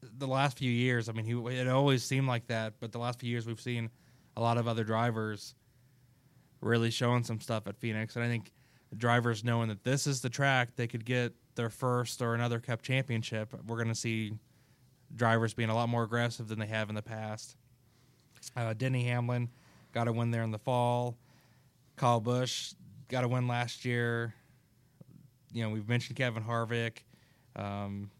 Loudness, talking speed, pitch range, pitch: -33 LUFS, 190 wpm, 115-125 Hz, 120 Hz